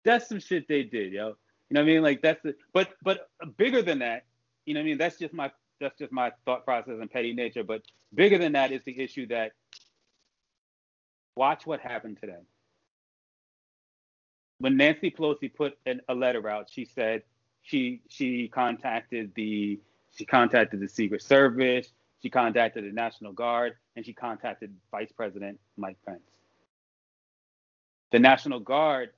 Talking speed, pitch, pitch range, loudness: 165 wpm, 125 Hz, 110-150 Hz, -27 LUFS